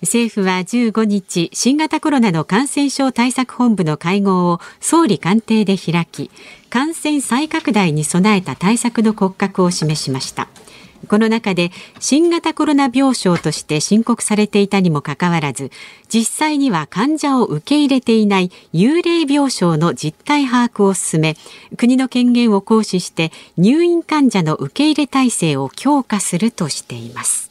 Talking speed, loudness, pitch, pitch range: 290 characters per minute, -16 LUFS, 210 Hz, 175-260 Hz